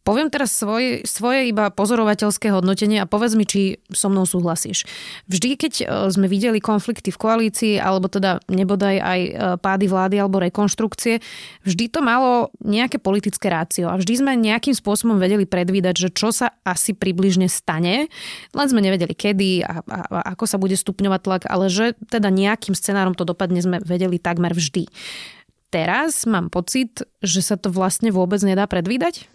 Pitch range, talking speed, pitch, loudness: 185-225 Hz, 165 wpm, 200 Hz, -19 LUFS